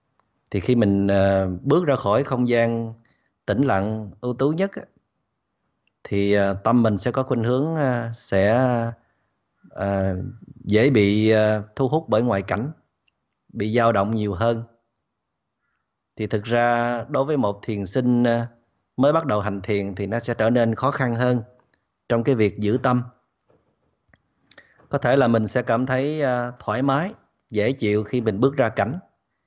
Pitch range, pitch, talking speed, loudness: 105-125 Hz, 115 Hz, 155 wpm, -22 LUFS